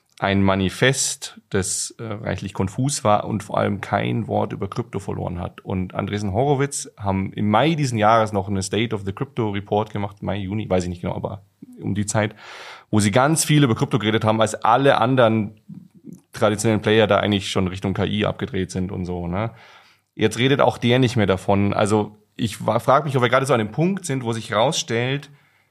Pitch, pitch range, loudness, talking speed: 105 Hz, 100-125 Hz, -21 LUFS, 200 wpm